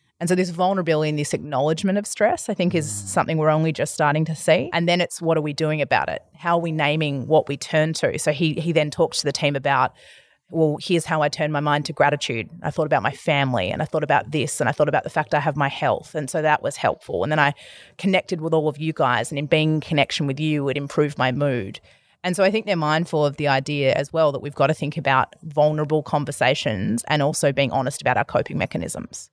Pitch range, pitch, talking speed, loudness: 145-165 Hz, 155 Hz, 260 wpm, -22 LUFS